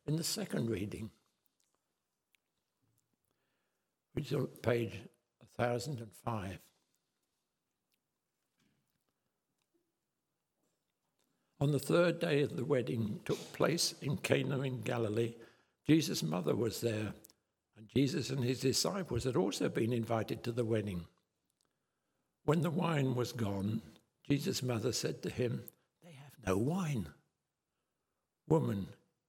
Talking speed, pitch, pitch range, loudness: 110 wpm, 120 Hz, 110-140 Hz, -36 LUFS